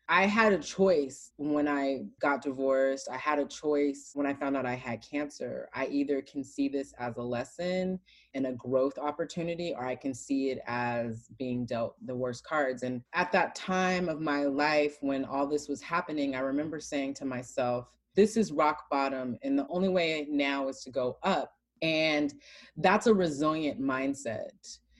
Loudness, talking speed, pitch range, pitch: -31 LUFS, 185 wpm, 130-155 Hz, 140 Hz